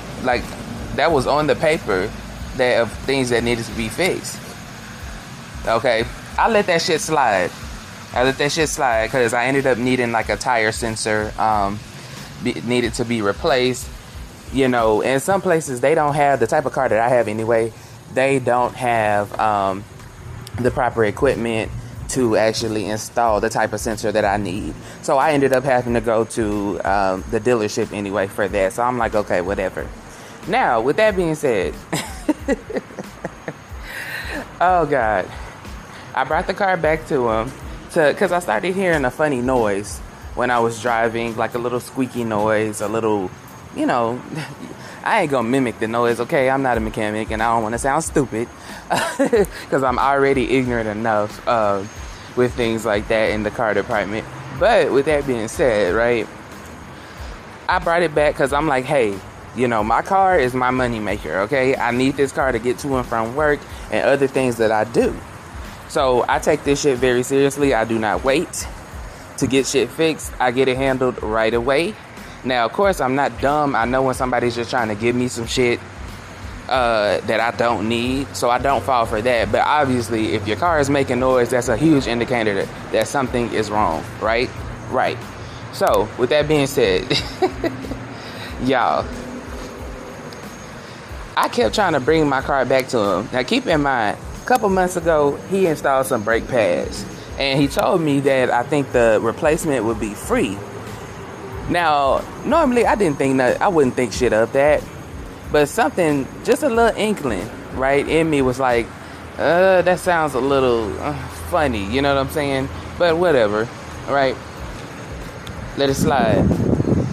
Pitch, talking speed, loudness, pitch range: 125 Hz, 180 wpm, -19 LUFS, 110-140 Hz